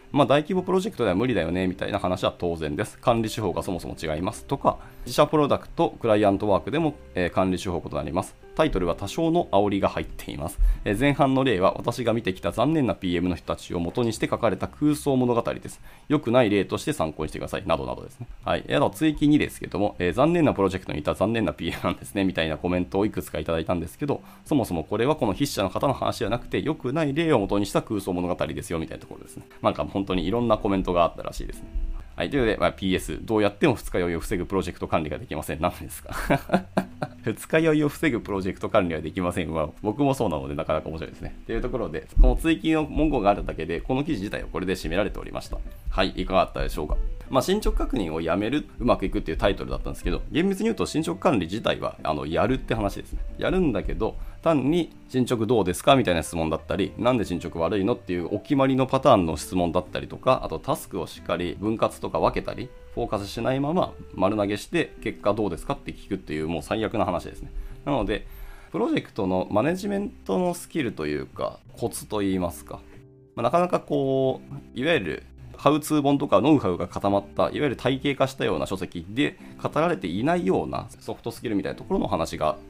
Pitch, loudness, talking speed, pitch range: 100 Hz, -25 LUFS, 495 characters per minute, 85-130 Hz